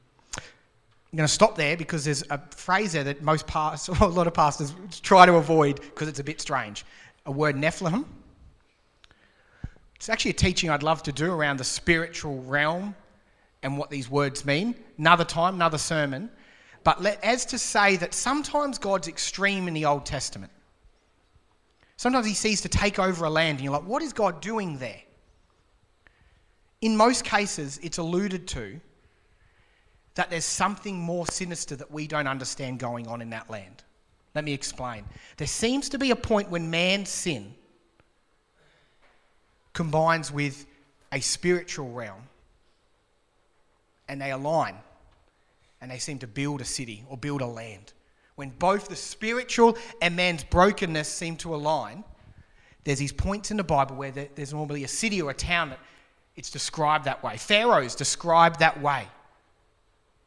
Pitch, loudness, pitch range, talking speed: 150 Hz, -25 LUFS, 130-180 Hz, 160 wpm